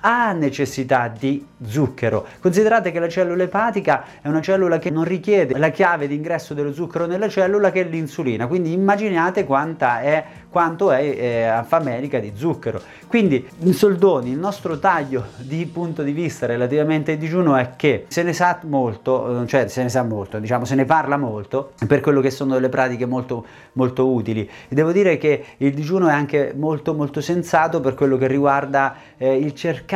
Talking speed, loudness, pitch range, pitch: 185 wpm, -19 LUFS, 130-170 Hz, 150 Hz